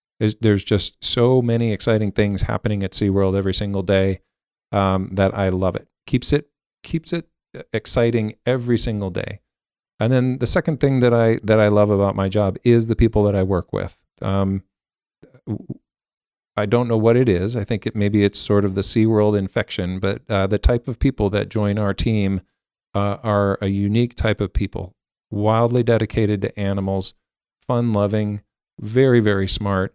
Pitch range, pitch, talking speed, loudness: 100-115 Hz, 105 Hz, 180 wpm, -20 LUFS